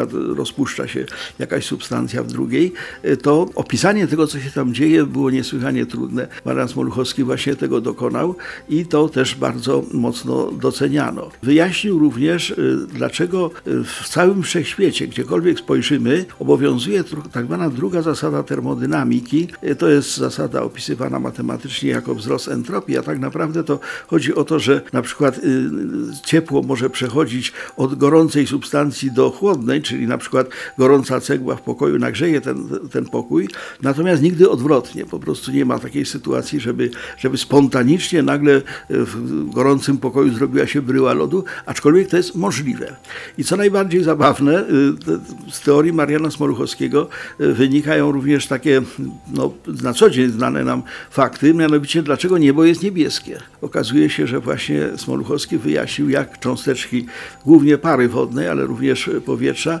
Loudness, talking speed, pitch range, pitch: -18 LUFS, 140 wpm, 130-165 Hz, 145 Hz